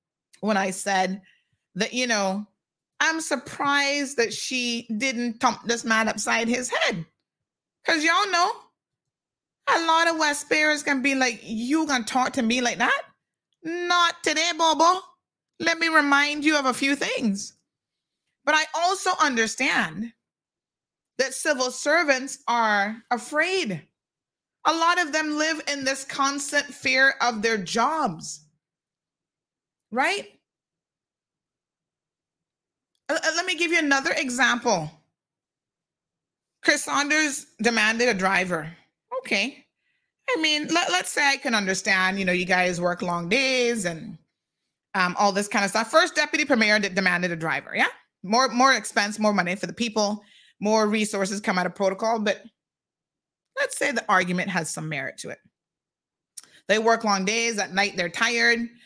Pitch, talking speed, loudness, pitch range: 240 Hz, 145 wpm, -23 LUFS, 200-295 Hz